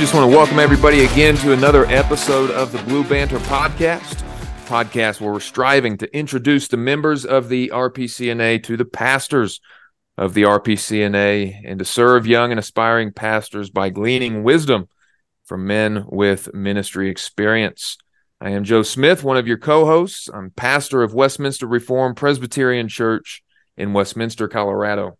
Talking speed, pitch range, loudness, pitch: 155 wpm, 105-135 Hz, -17 LUFS, 120 Hz